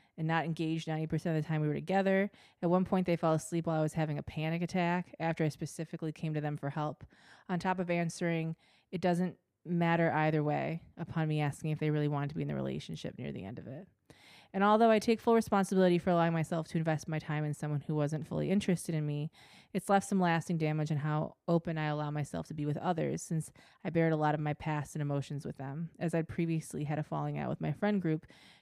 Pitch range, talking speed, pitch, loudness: 150-175 Hz, 245 wpm, 160 Hz, -33 LUFS